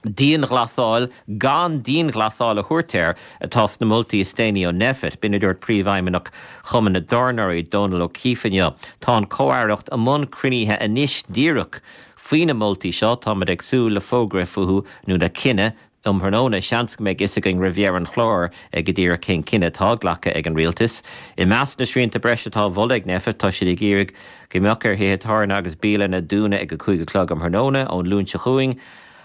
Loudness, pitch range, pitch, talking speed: -19 LUFS, 95-120 Hz, 105 Hz, 145 wpm